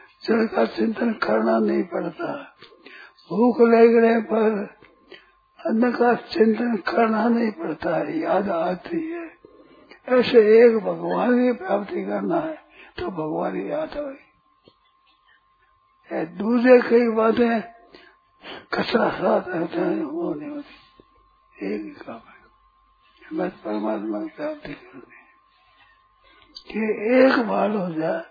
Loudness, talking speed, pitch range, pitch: -21 LUFS, 110 wpm, 220-335 Hz, 245 Hz